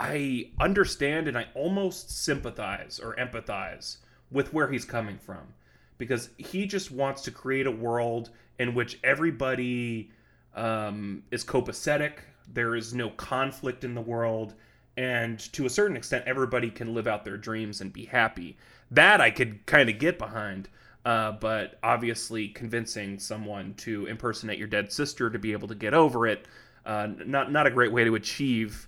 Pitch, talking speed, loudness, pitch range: 115 Hz, 165 wpm, -28 LUFS, 110-130 Hz